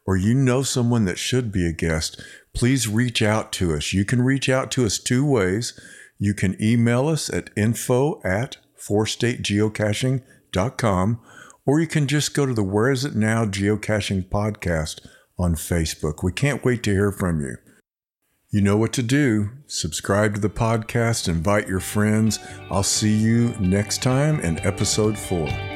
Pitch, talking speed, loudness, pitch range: 110 Hz, 170 wpm, -22 LUFS, 100-125 Hz